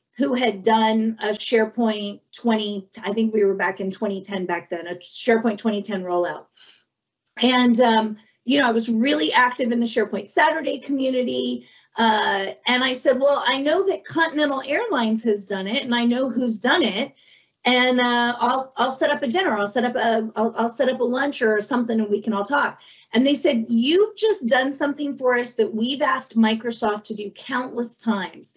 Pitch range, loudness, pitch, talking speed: 215-260 Hz, -21 LUFS, 235 Hz, 195 wpm